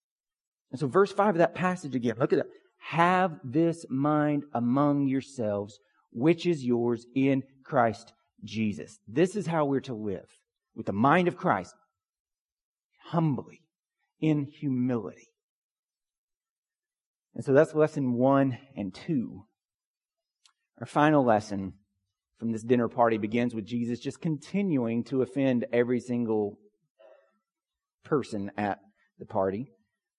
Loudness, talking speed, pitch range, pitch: -28 LUFS, 125 wpm, 115-155 Hz, 135 Hz